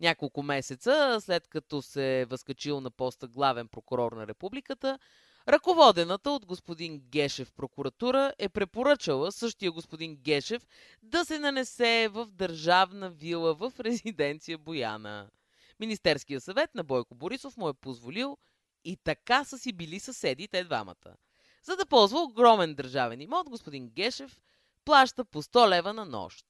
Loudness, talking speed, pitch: -28 LUFS, 140 wpm, 180 Hz